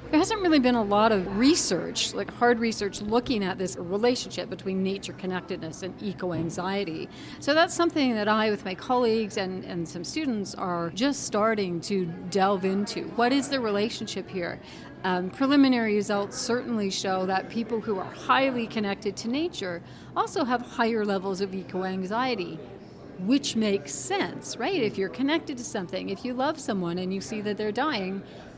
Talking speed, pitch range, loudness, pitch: 175 wpm, 190-245 Hz, -27 LUFS, 210 Hz